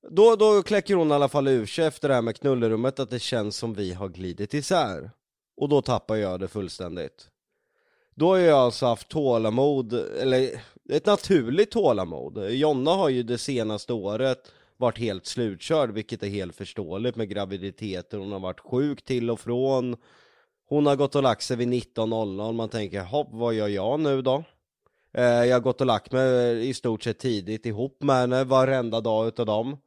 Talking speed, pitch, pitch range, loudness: 185 wpm, 120 Hz, 110-135 Hz, -25 LUFS